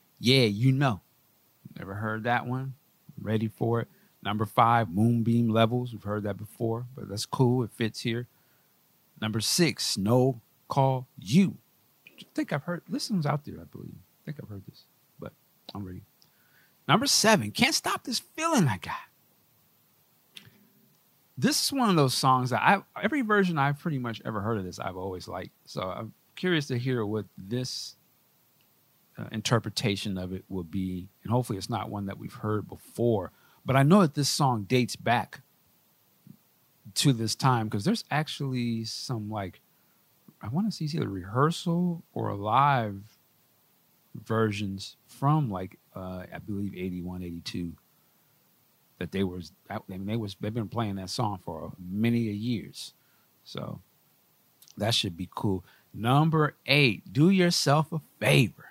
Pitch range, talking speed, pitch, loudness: 100-140 Hz, 160 wpm, 115 Hz, -28 LUFS